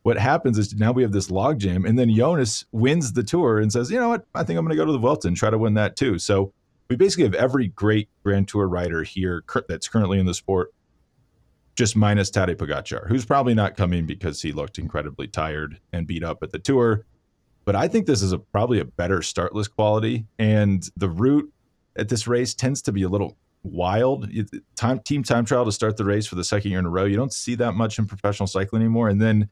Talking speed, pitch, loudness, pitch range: 240 wpm, 105 Hz, -22 LUFS, 95-120 Hz